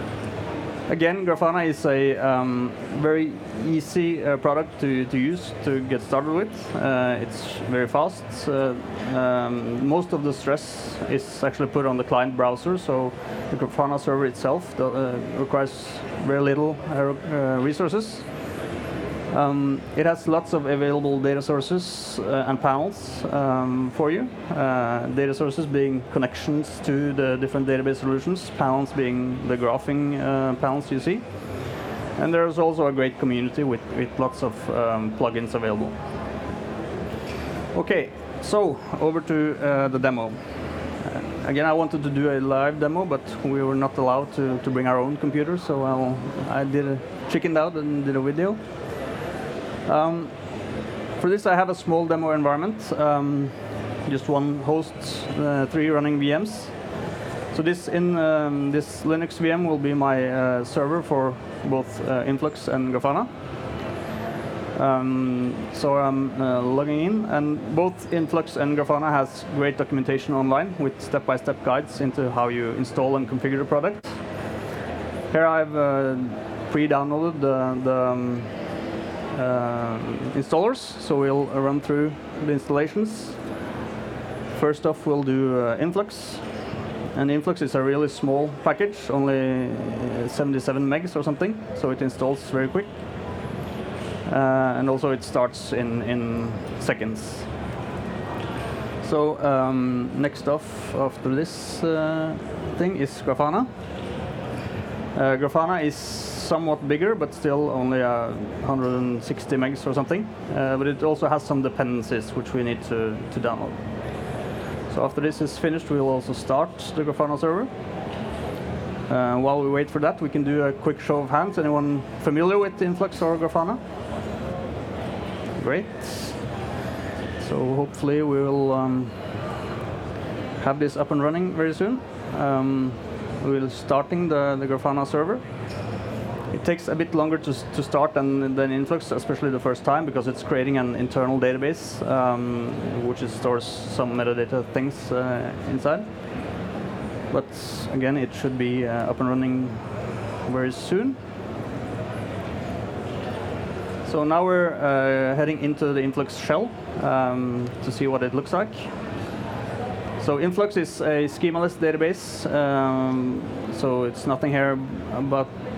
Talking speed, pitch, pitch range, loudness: 140 wpm, 135 Hz, 125-150 Hz, -25 LUFS